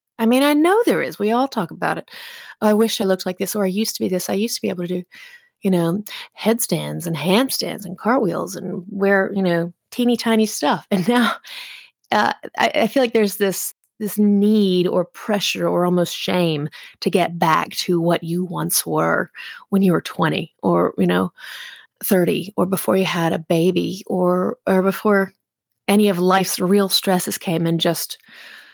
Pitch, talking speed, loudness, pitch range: 195 Hz, 195 wpm, -19 LUFS, 180-220 Hz